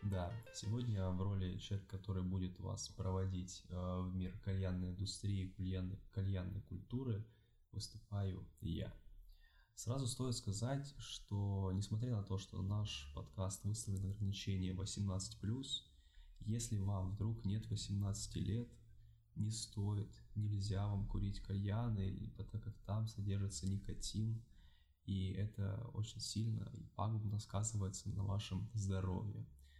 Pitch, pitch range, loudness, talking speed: 100 Hz, 95-110 Hz, -44 LUFS, 120 wpm